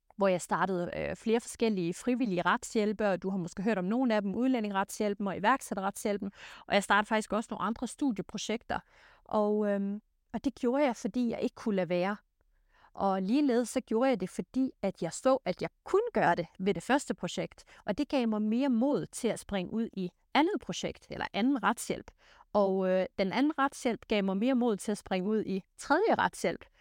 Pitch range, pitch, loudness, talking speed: 195-245 Hz, 215 Hz, -31 LUFS, 200 wpm